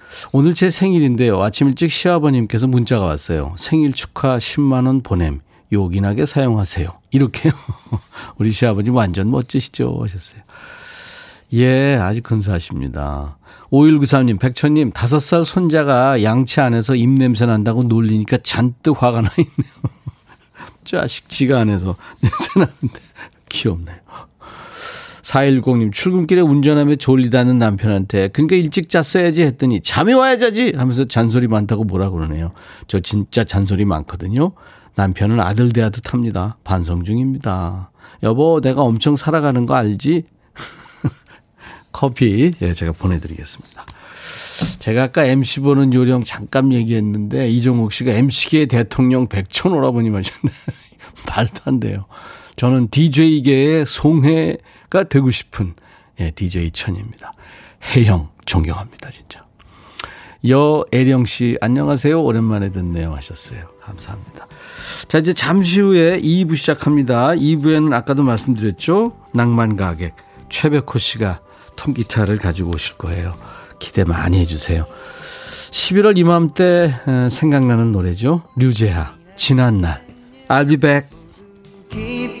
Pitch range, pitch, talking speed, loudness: 100-150 Hz, 125 Hz, 290 characters per minute, -16 LUFS